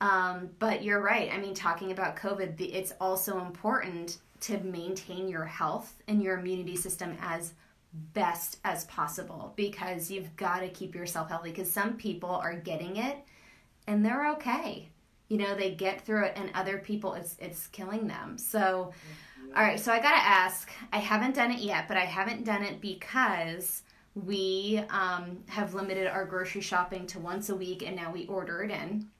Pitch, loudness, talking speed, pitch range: 190 Hz, -31 LUFS, 180 wpm, 180-205 Hz